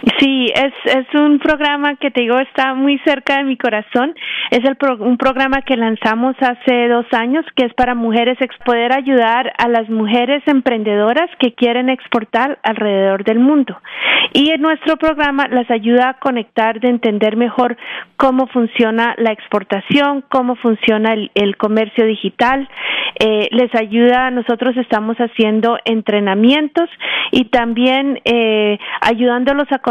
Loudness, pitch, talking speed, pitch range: -14 LUFS, 245 Hz, 150 wpm, 225-270 Hz